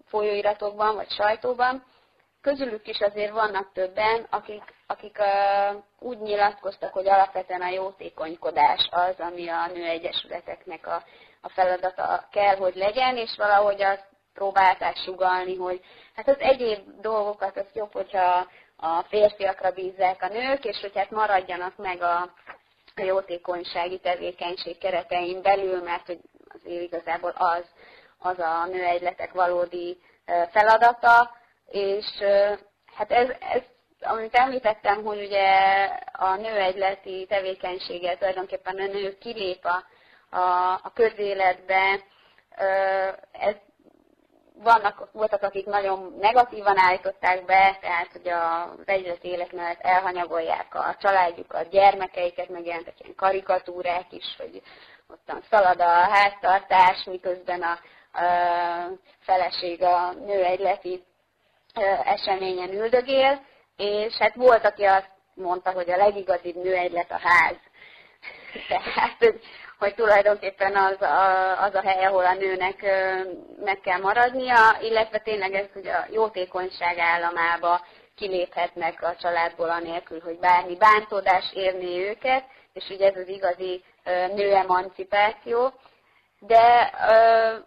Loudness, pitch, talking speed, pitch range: -23 LUFS, 190 Hz, 115 wpm, 180-210 Hz